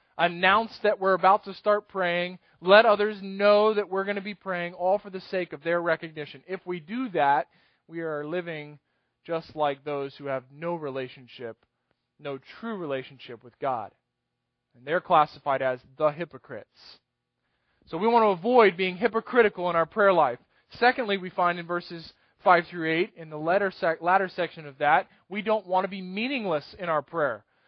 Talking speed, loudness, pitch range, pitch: 180 wpm, -26 LUFS, 150-200 Hz, 175 Hz